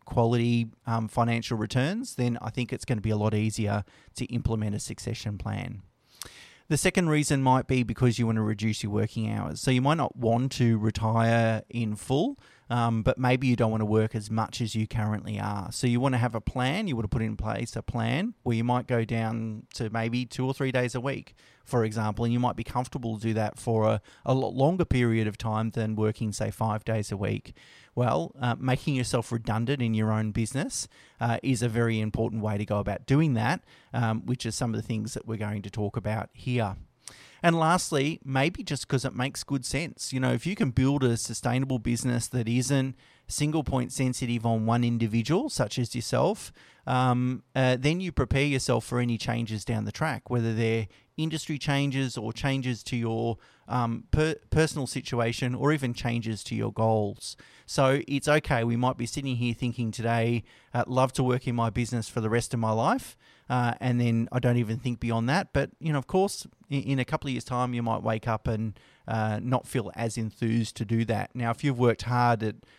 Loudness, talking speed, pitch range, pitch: -28 LUFS, 215 wpm, 115-130 Hz, 120 Hz